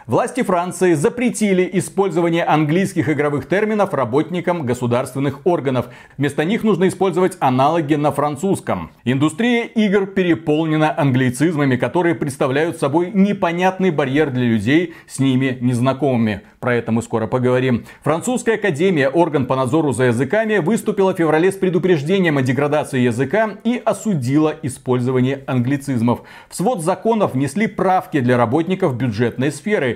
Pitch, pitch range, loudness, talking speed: 155 Hz, 130-185 Hz, -18 LUFS, 130 wpm